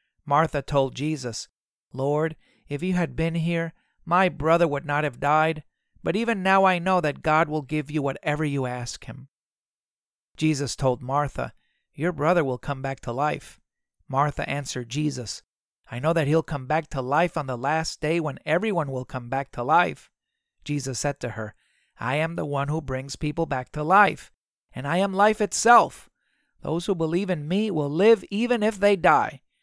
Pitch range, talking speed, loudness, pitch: 140-170 Hz, 185 wpm, -24 LUFS, 150 Hz